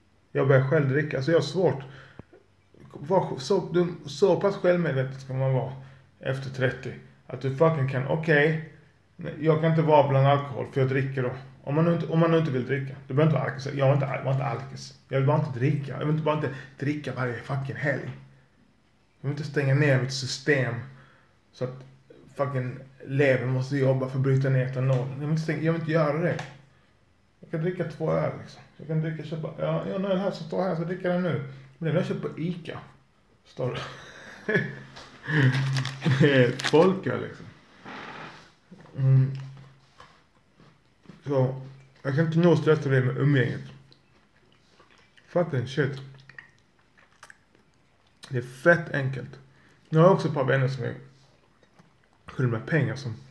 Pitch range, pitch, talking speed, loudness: 130-160 Hz, 135 Hz, 170 wpm, -26 LUFS